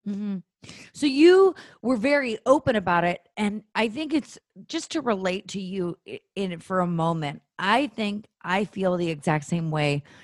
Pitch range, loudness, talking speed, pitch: 175-255 Hz, -25 LUFS, 175 wpm, 200 Hz